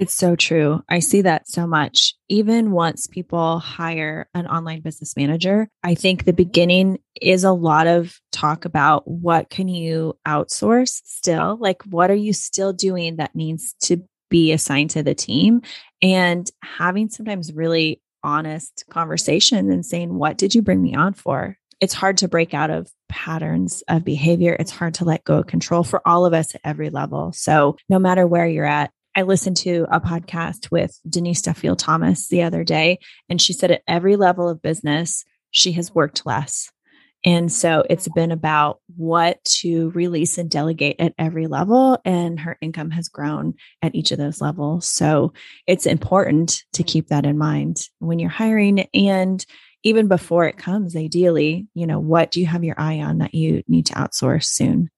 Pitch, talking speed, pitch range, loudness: 170 Hz, 185 wpm, 155-185 Hz, -19 LUFS